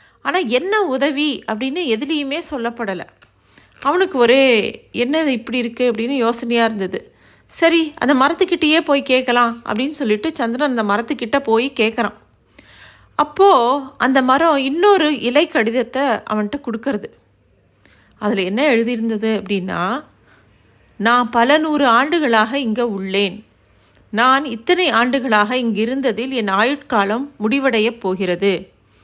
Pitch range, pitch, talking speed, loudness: 215-280 Hz, 240 Hz, 105 wpm, -17 LUFS